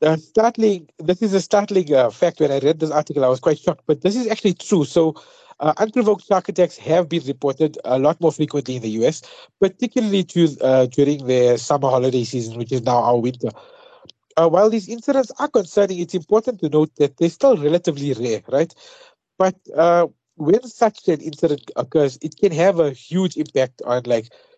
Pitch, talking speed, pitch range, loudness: 165 Hz, 200 wpm, 140-200 Hz, -19 LUFS